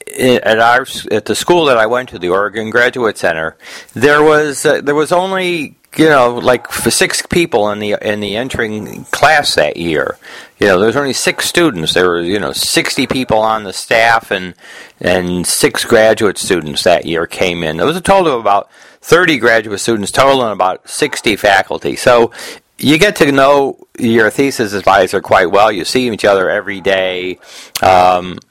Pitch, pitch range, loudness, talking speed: 115 Hz, 100-135 Hz, -12 LUFS, 185 wpm